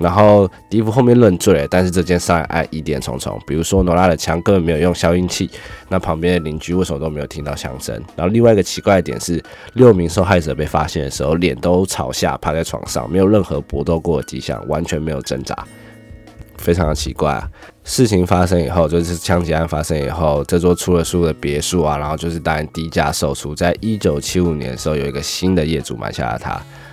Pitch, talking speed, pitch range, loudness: 85 Hz, 350 characters per minute, 75-90 Hz, -17 LUFS